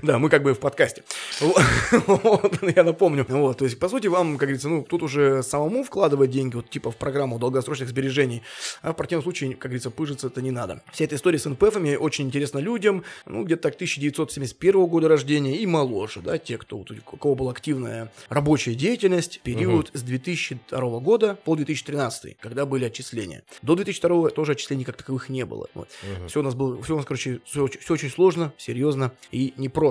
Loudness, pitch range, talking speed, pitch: -23 LUFS, 130-165 Hz, 185 wpm, 140 Hz